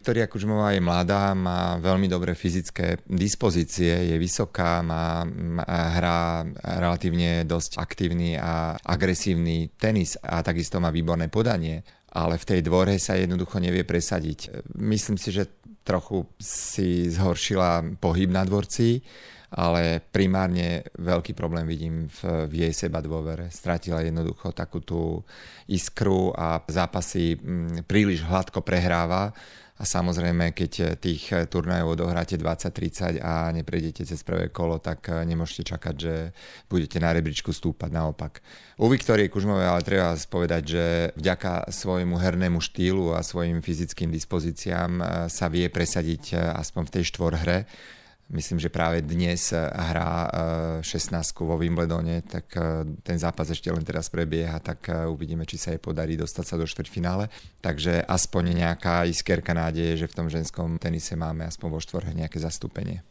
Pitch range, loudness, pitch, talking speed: 80-90 Hz, -26 LUFS, 85 Hz, 140 wpm